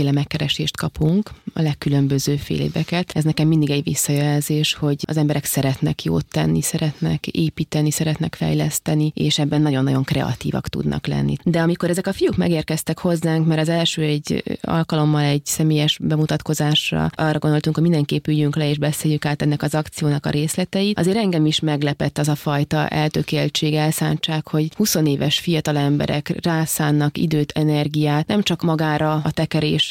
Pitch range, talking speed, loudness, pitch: 145-160 Hz, 160 wpm, -20 LUFS, 155 Hz